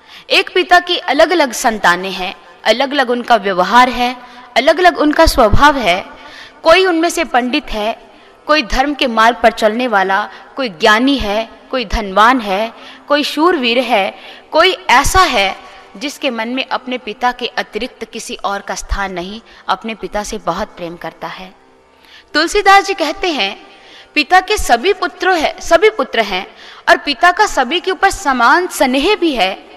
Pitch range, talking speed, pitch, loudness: 220-330 Hz, 170 wpm, 260 Hz, -13 LUFS